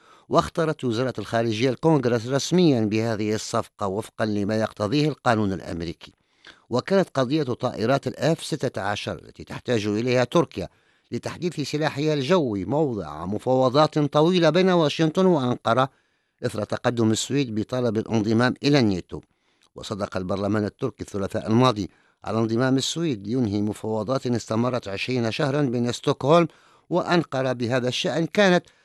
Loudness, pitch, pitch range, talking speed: -23 LUFS, 125 Hz, 110-150 Hz, 115 wpm